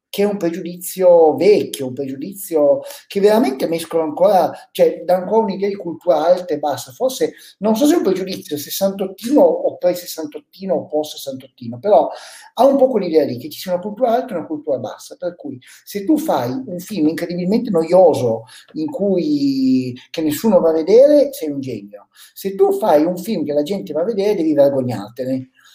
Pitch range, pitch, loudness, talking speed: 150-220 Hz, 180 Hz, -17 LUFS, 190 wpm